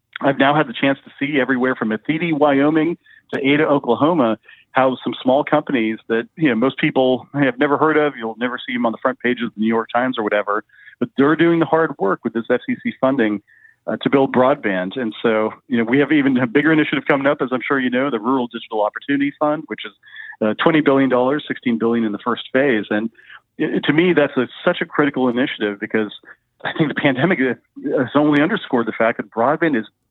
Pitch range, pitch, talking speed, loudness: 115-145 Hz, 130 Hz, 220 wpm, -18 LUFS